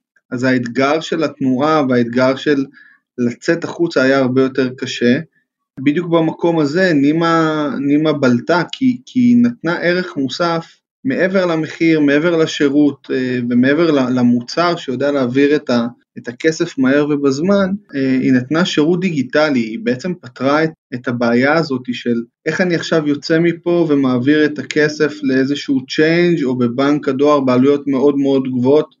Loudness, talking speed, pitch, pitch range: -15 LUFS, 135 wpm, 145 Hz, 130-165 Hz